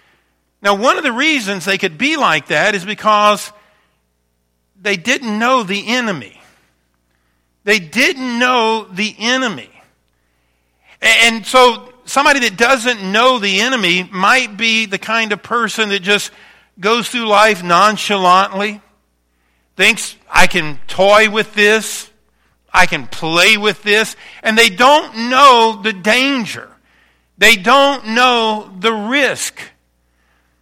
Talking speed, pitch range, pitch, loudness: 125 wpm, 180-235 Hz, 210 Hz, -12 LUFS